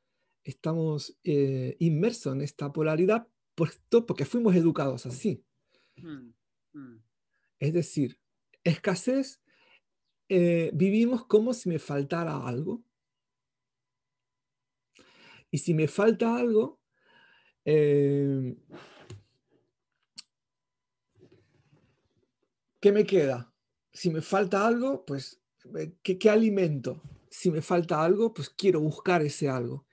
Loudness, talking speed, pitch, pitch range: -27 LUFS, 90 wpm, 155 Hz, 130-190 Hz